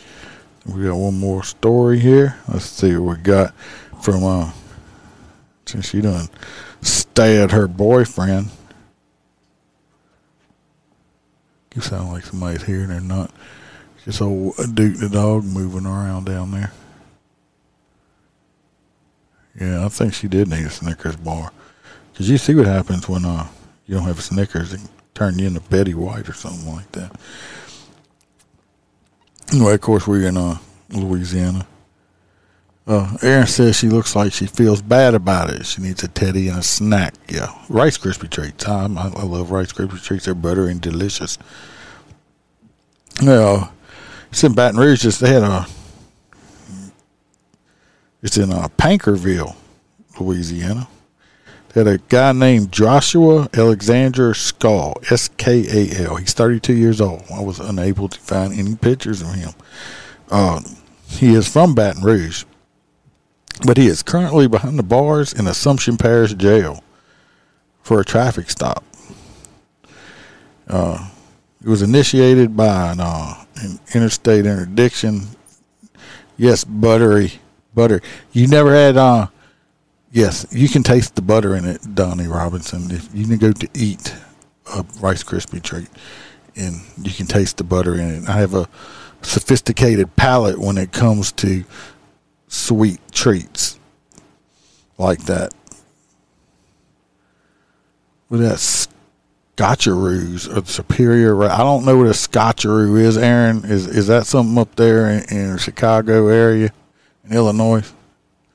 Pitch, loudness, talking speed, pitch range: 100 Hz, -16 LUFS, 140 wpm, 90-115 Hz